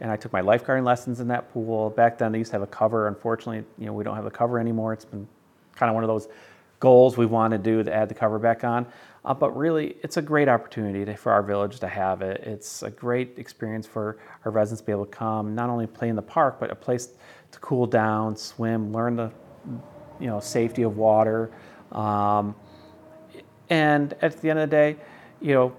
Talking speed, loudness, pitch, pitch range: 235 wpm, -24 LUFS, 115 Hz, 110-125 Hz